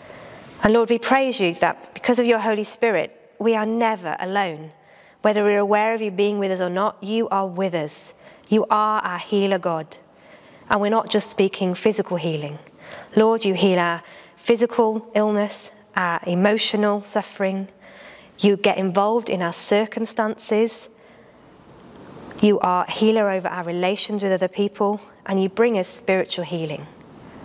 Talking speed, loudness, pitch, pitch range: 160 wpm, -21 LUFS, 205 Hz, 190-220 Hz